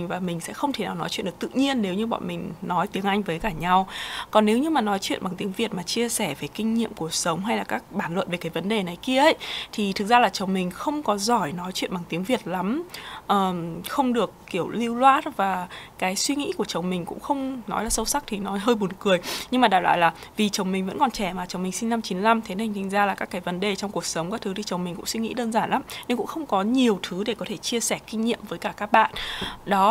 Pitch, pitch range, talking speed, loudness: 200 Hz, 185-230 Hz, 295 wpm, -25 LUFS